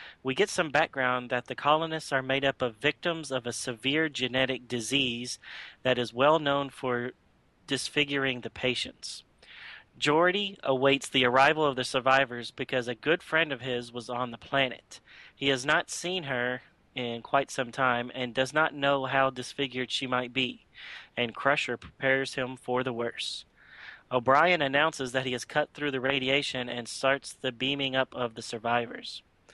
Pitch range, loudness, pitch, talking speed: 125-140 Hz, -28 LUFS, 130 Hz, 170 wpm